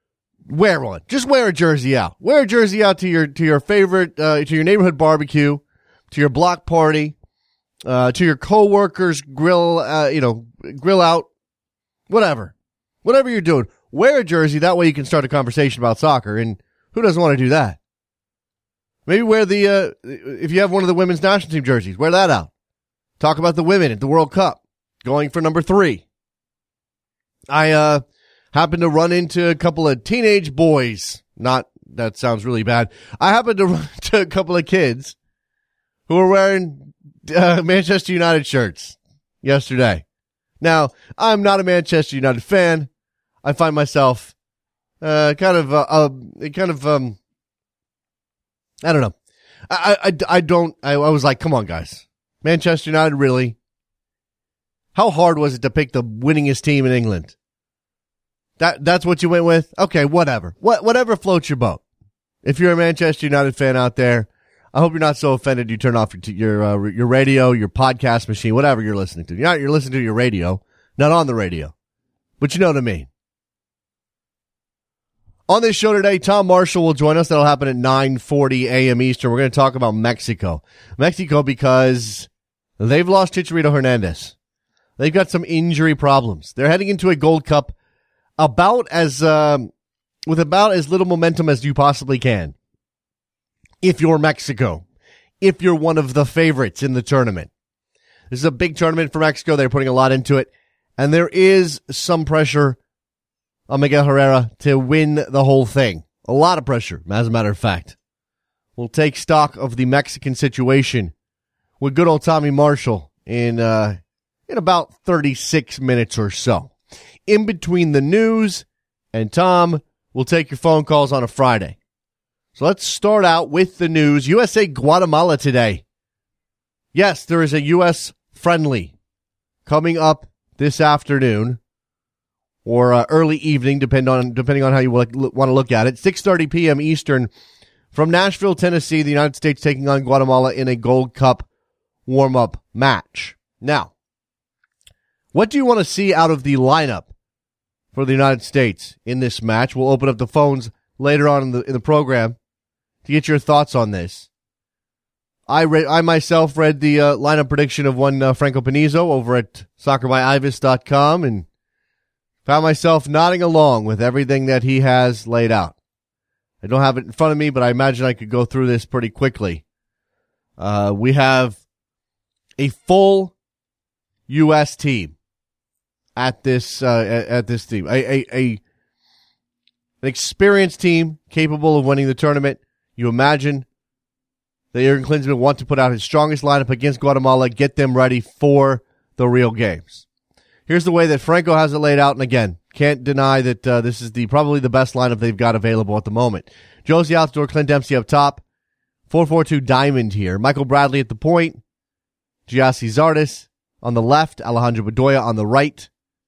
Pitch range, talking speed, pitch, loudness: 125-160 Hz, 175 wpm, 140 Hz, -16 LUFS